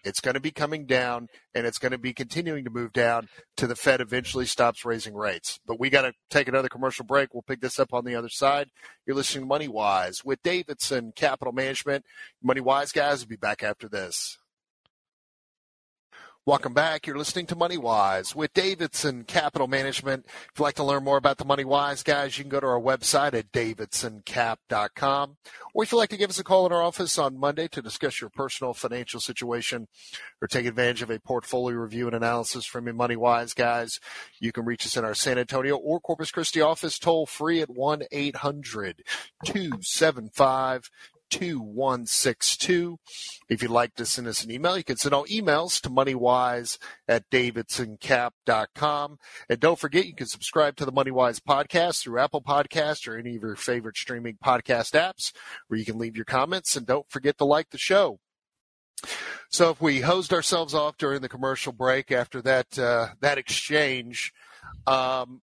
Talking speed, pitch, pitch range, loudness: 185 wpm, 130 Hz, 120-150 Hz, -26 LUFS